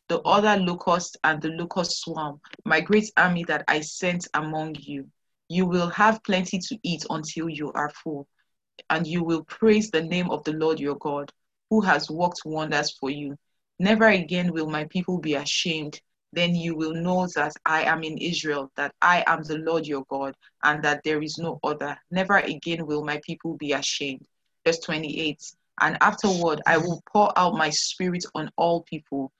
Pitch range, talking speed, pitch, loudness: 150-175 Hz, 185 wpm, 160 Hz, -24 LUFS